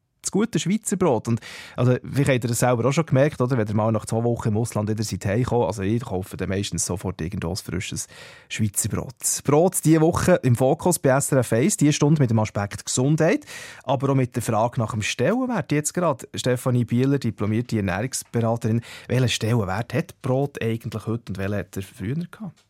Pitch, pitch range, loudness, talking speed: 120 Hz, 110-140 Hz, -23 LUFS, 195 wpm